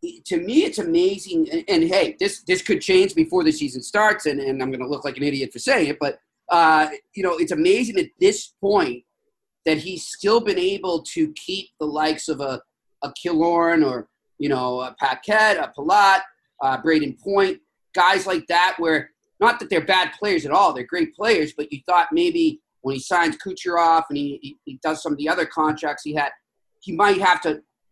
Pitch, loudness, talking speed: 180 Hz, -21 LUFS, 210 wpm